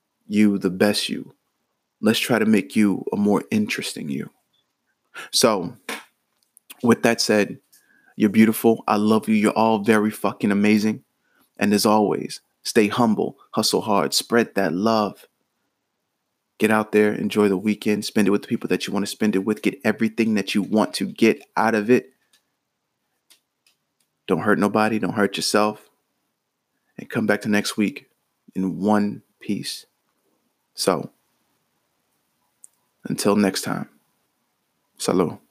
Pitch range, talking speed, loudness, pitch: 105-110 Hz, 145 wpm, -21 LUFS, 105 Hz